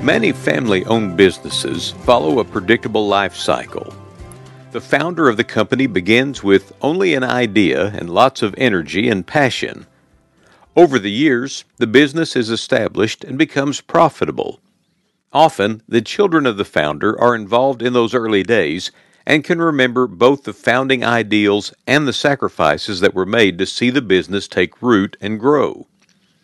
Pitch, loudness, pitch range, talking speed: 120 Hz, -16 LUFS, 100-135 Hz, 150 wpm